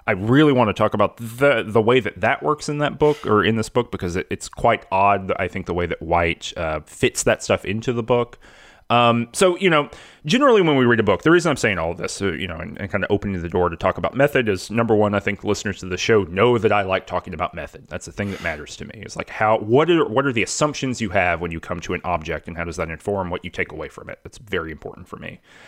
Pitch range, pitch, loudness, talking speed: 90-120 Hz, 100 Hz, -20 LUFS, 290 wpm